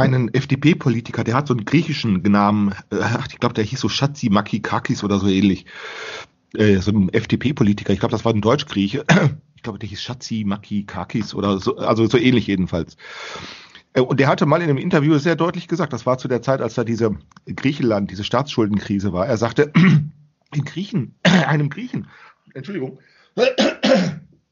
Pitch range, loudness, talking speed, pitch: 105-150 Hz, -19 LUFS, 170 wpm, 120 Hz